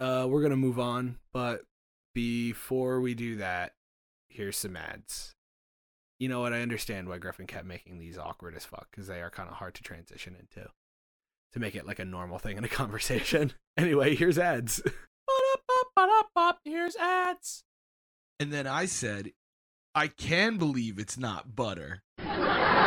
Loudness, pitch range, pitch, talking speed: -30 LUFS, 95-145 Hz, 120 Hz, 155 wpm